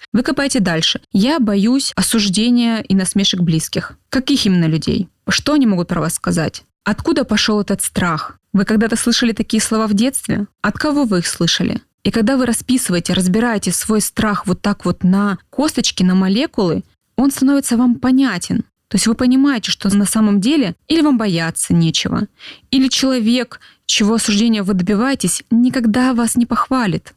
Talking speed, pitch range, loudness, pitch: 165 wpm, 200-250 Hz, -16 LUFS, 220 Hz